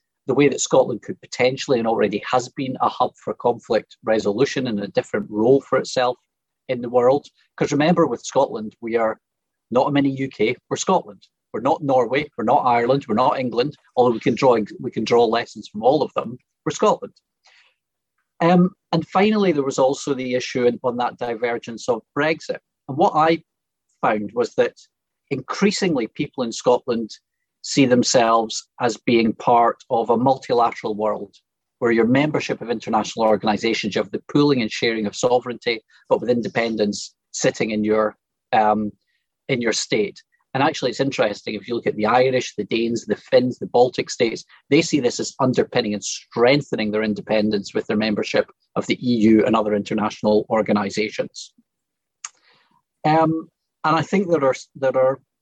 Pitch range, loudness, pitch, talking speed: 110-145 Hz, -20 LUFS, 125 Hz, 170 wpm